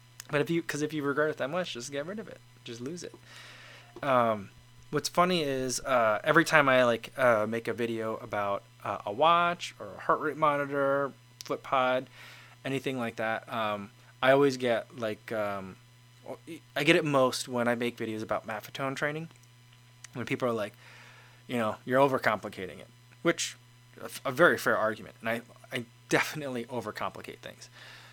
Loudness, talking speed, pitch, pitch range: -29 LUFS, 175 wpm, 125 Hz, 115-140 Hz